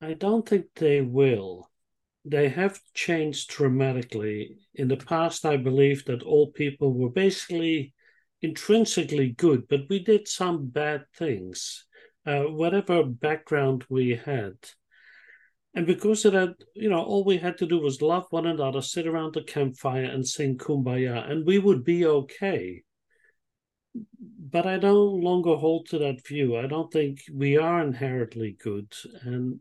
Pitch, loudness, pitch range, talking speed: 150 Hz, -25 LUFS, 135-175 Hz, 150 wpm